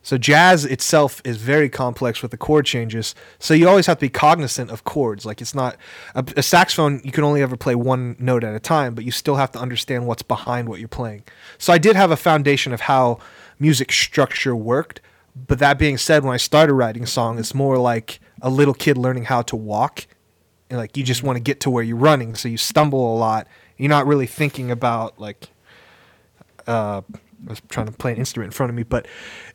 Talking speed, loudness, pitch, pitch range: 225 wpm, -18 LUFS, 125 Hz, 115-145 Hz